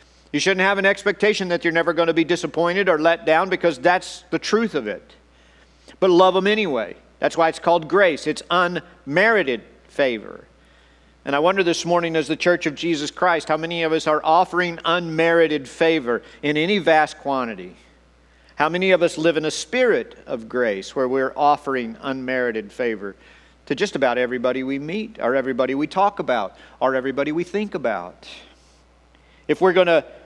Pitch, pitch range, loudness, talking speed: 160 Hz, 130-180 Hz, -20 LUFS, 180 wpm